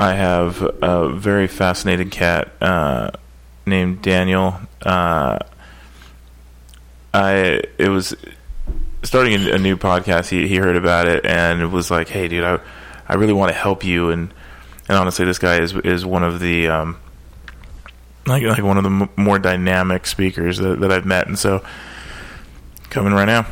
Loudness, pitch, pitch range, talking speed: -17 LUFS, 90 Hz, 75-95 Hz, 165 wpm